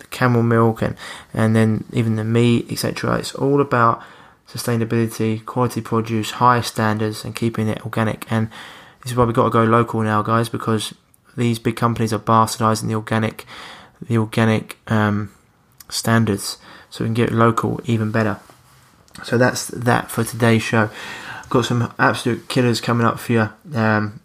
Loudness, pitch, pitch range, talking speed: -19 LUFS, 115 Hz, 110-120 Hz, 165 wpm